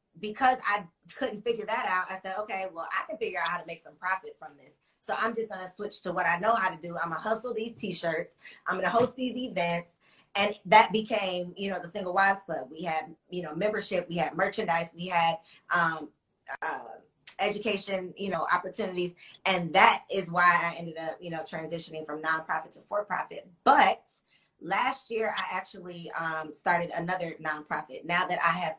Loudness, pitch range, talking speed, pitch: -29 LUFS, 170-205 Hz, 210 wpm, 180 Hz